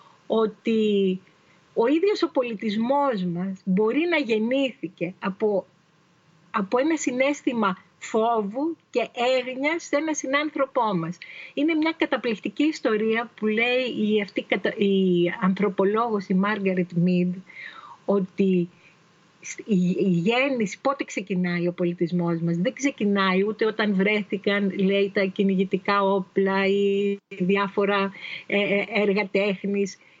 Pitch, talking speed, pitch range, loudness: 200 Hz, 105 wpm, 190-240 Hz, -24 LUFS